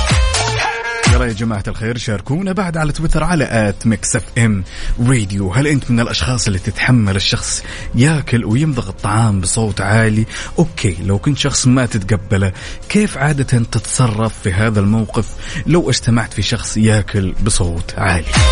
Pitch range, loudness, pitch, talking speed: 105-125 Hz, -16 LUFS, 110 Hz, 140 wpm